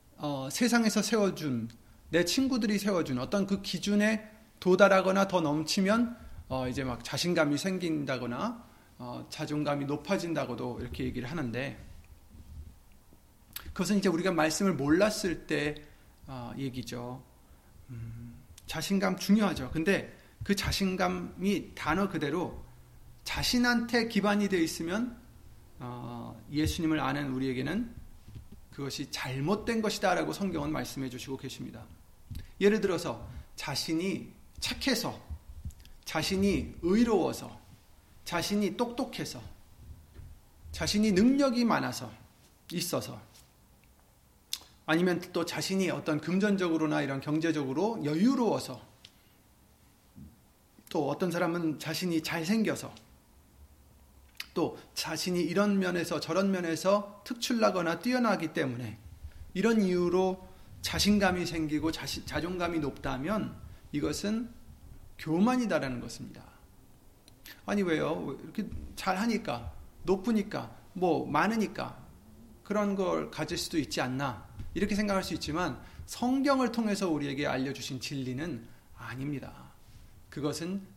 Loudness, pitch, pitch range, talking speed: -31 LUFS, 160 Hz, 125-195 Hz, 260 characters per minute